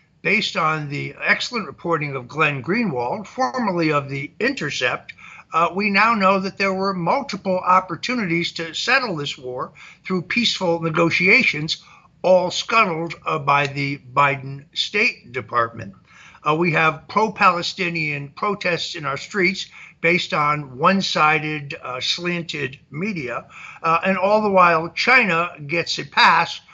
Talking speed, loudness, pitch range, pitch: 135 wpm, -19 LUFS, 150-195 Hz, 170 Hz